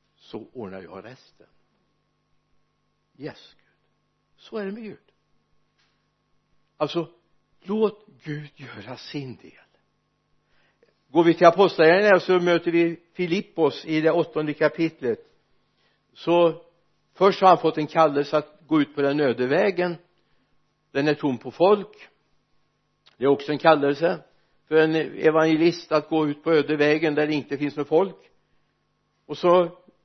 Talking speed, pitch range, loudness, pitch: 140 wpm, 150-175 Hz, -22 LUFS, 160 Hz